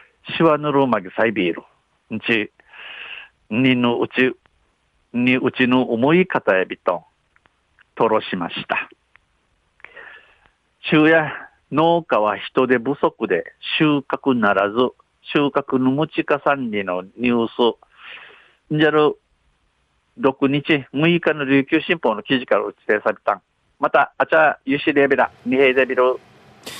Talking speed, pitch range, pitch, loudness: 225 characters per minute, 120-155 Hz, 135 Hz, -19 LUFS